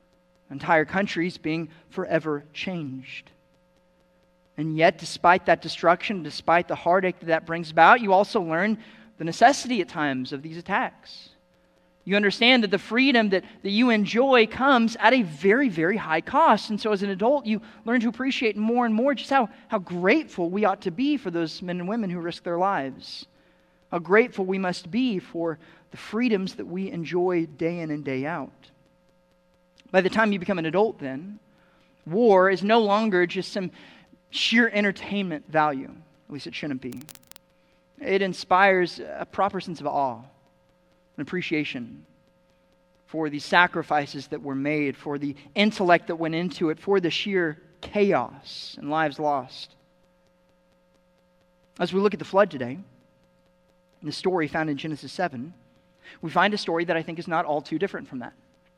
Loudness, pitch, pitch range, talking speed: -24 LUFS, 180 Hz, 155-200 Hz, 170 wpm